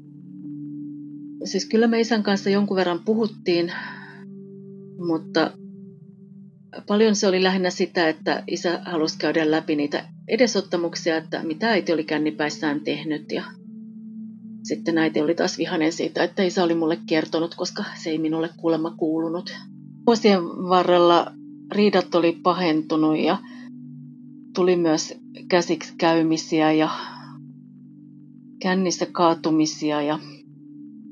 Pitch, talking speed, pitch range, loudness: 175 Hz, 115 wpm, 160-195 Hz, -22 LUFS